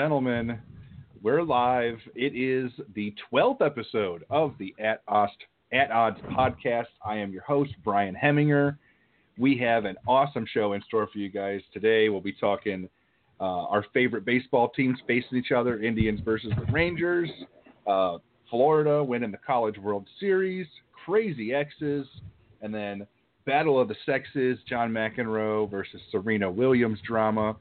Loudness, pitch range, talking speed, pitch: -27 LUFS, 105-135 Hz, 150 wpm, 115 Hz